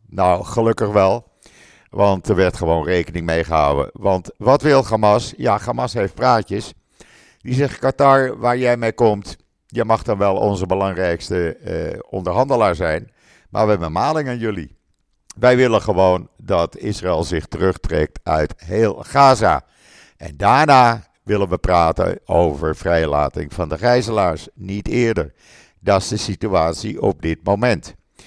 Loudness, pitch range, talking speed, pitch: -18 LUFS, 85-115 Hz, 145 wpm, 100 Hz